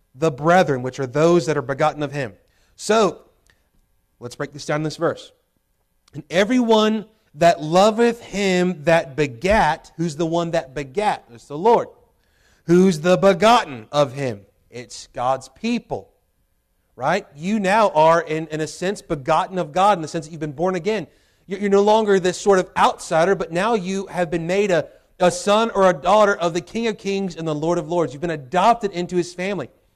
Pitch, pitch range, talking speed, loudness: 175 Hz, 150-195 Hz, 190 wpm, -19 LUFS